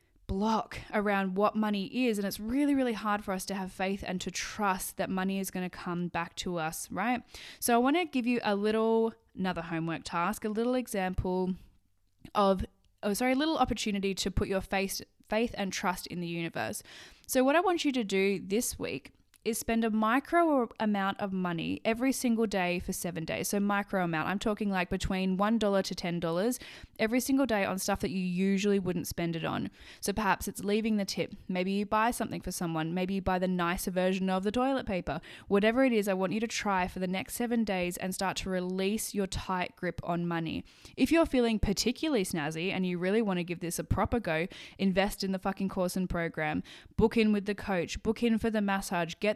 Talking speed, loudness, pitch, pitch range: 220 wpm, -31 LUFS, 195 Hz, 185-225 Hz